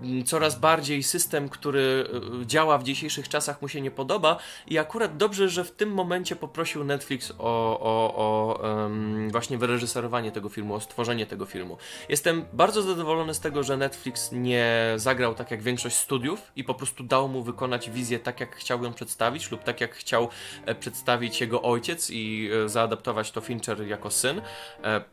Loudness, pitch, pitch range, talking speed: -27 LUFS, 125 Hz, 115-150 Hz, 170 wpm